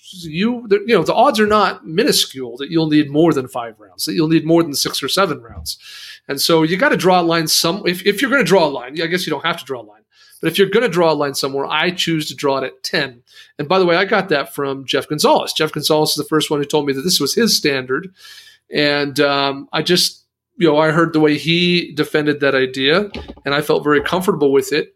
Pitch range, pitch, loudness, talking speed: 145-180 Hz, 155 Hz, -16 LUFS, 265 wpm